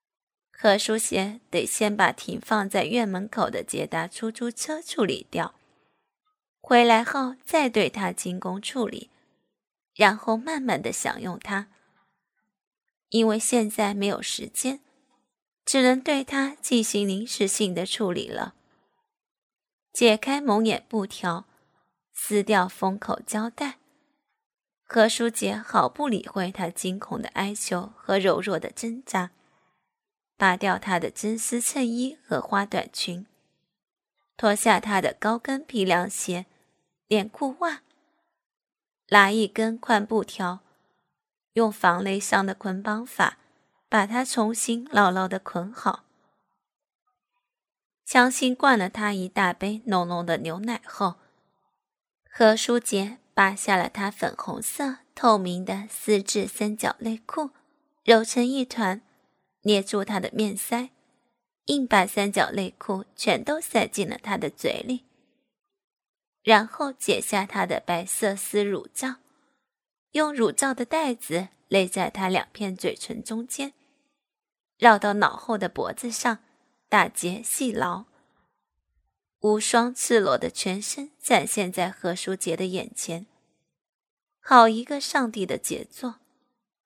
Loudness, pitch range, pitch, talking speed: -25 LUFS, 195-250 Hz, 220 Hz, 180 characters per minute